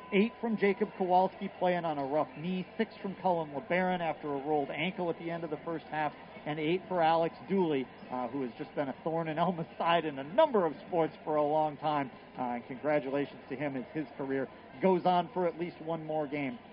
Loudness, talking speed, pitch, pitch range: -33 LUFS, 230 wpm, 165 Hz, 150-180 Hz